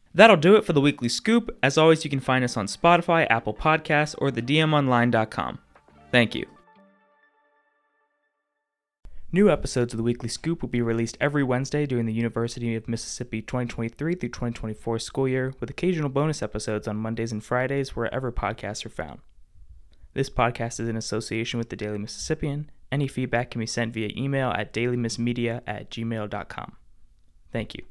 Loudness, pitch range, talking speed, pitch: -25 LUFS, 115-145 Hz, 165 wpm, 120 Hz